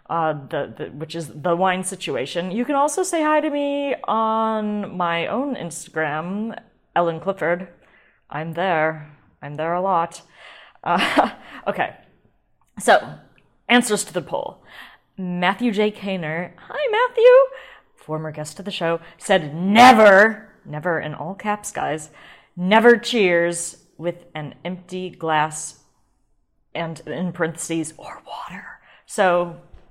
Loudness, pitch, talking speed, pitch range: -20 LUFS, 180 Hz, 125 wpm, 165-210 Hz